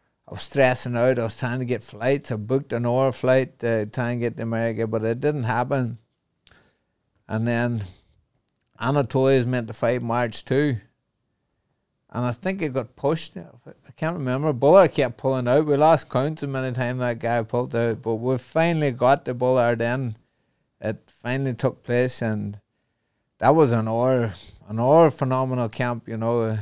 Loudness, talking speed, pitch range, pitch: -23 LUFS, 180 wpm, 115-135 Hz, 125 Hz